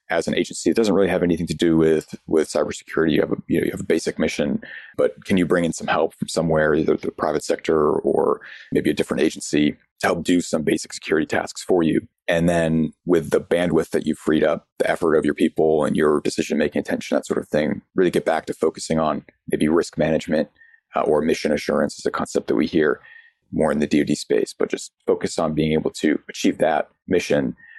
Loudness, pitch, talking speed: -21 LUFS, 95 Hz, 230 wpm